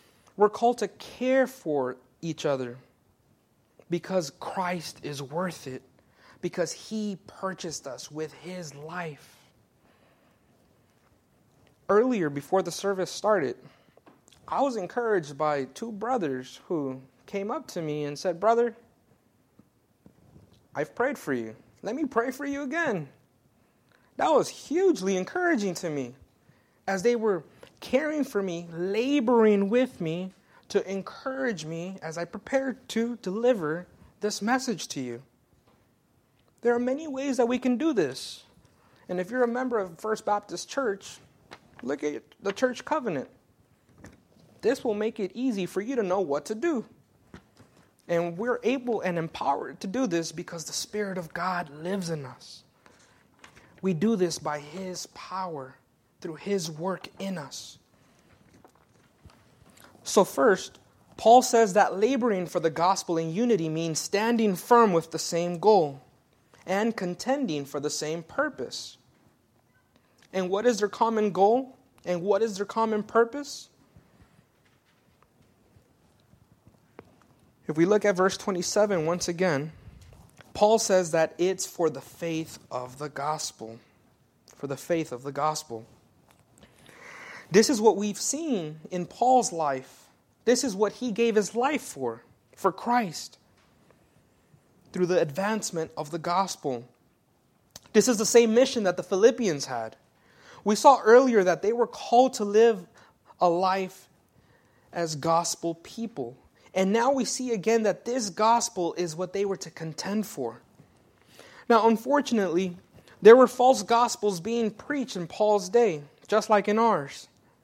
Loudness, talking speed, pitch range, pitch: -26 LUFS, 140 wpm, 165-230 Hz, 195 Hz